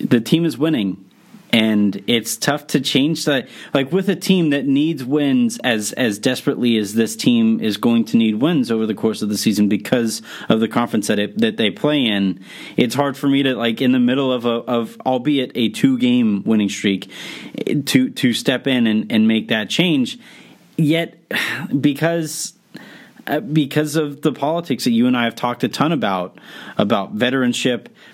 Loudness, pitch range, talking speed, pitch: -18 LUFS, 115-160 Hz, 190 wpm, 130 Hz